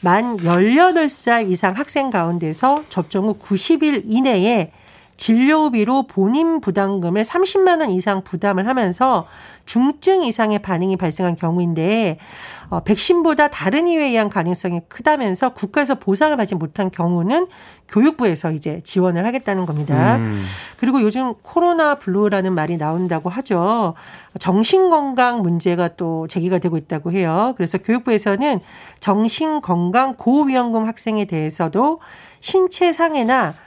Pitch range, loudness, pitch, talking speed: 180-265 Hz, -18 LUFS, 210 Hz, 305 characters per minute